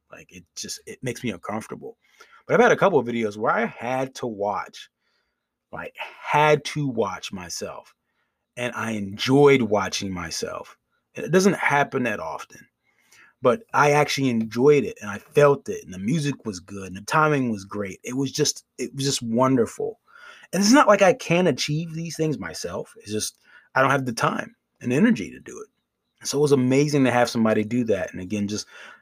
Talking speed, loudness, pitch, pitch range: 195 wpm, -22 LUFS, 140 Hz, 115-170 Hz